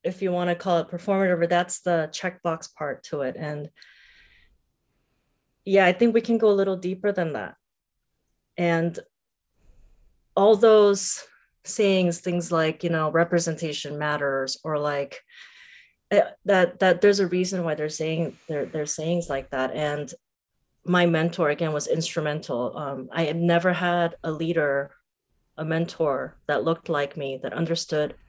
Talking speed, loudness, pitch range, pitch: 155 wpm, -24 LUFS, 150-185 Hz, 170 Hz